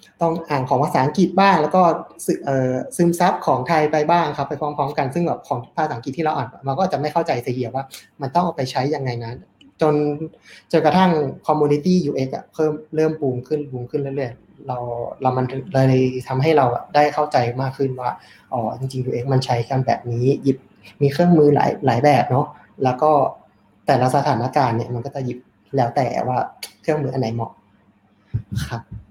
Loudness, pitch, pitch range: -20 LUFS, 140 Hz, 130-155 Hz